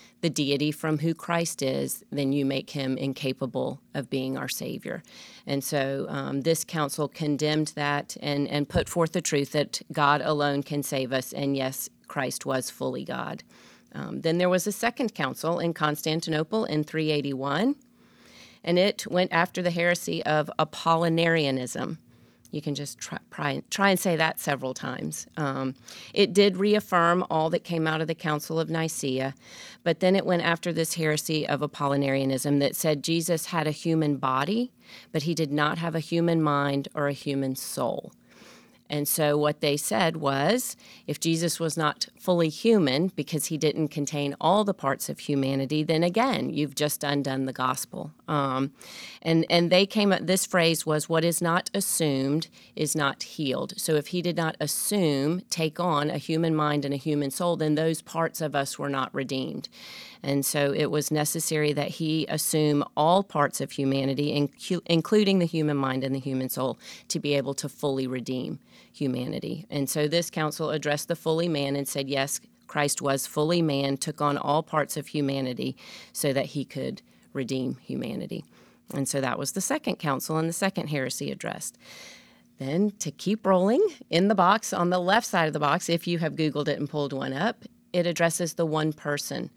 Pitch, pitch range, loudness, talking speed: 155 Hz, 140-170 Hz, -27 LUFS, 180 wpm